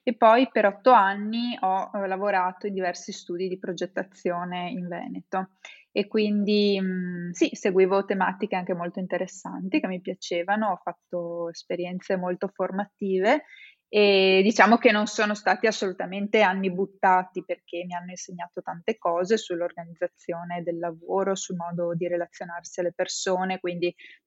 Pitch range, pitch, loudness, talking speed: 175-205 Hz, 185 Hz, -25 LUFS, 135 wpm